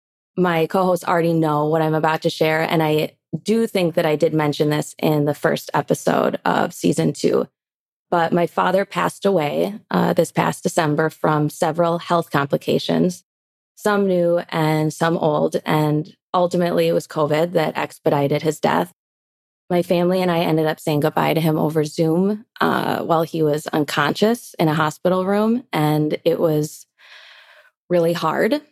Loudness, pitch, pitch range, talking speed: -19 LUFS, 165 Hz, 155-180 Hz, 165 wpm